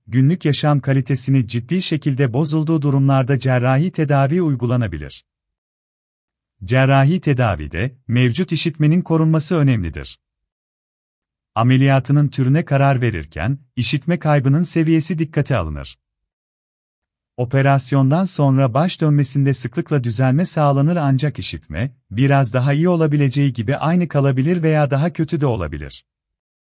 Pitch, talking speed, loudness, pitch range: 135 Hz, 105 wpm, -17 LUFS, 110-150 Hz